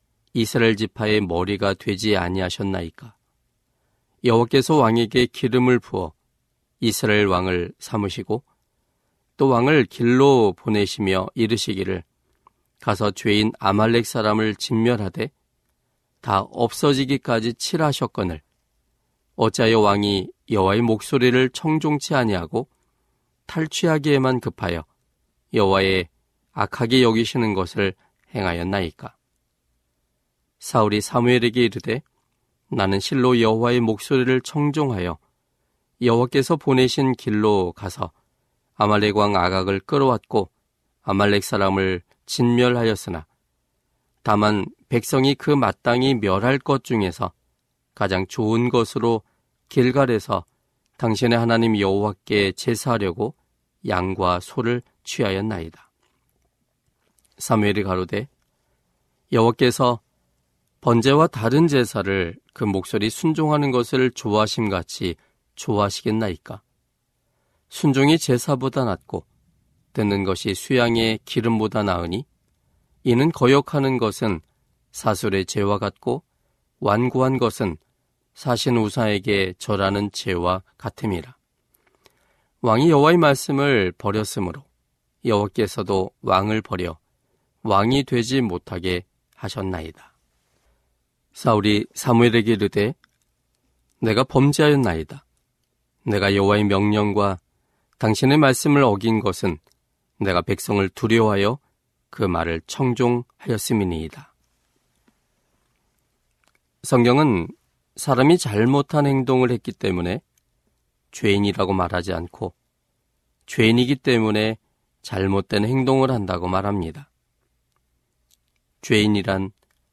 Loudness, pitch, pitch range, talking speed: -21 LUFS, 110 Hz, 95-125 Hz, 245 characters per minute